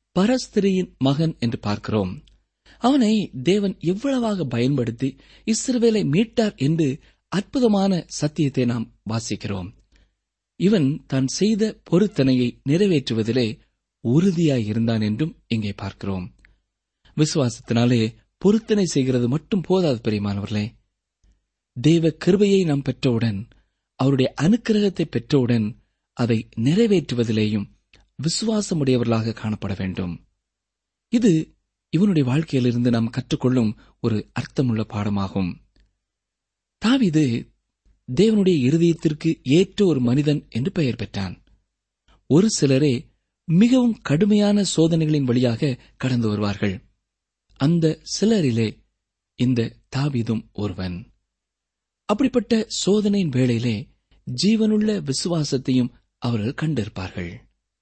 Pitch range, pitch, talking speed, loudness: 105-170 Hz, 125 Hz, 80 wpm, -21 LUFS